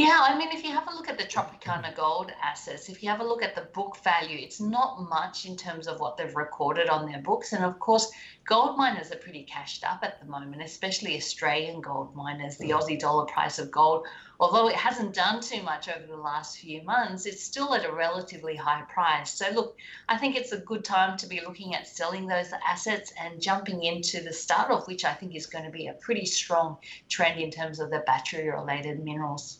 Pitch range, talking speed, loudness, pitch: 155-205 Hz, 230 wpm, -28 LUFS, 170 Hz